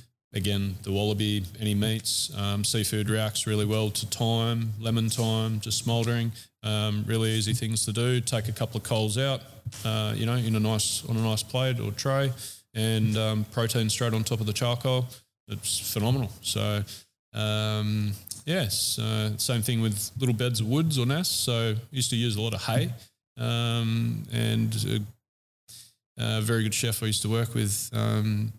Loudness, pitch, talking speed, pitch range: -27 LUFS, 110 Hz, 180 wpm, 105-120 Hz